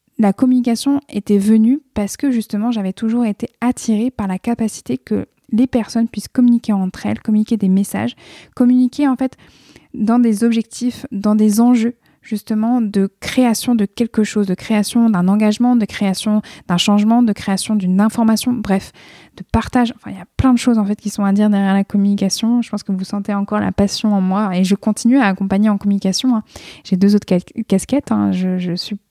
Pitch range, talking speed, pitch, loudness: 200-235 Hz, 200 wpm, 215 Hz, -16 LUFS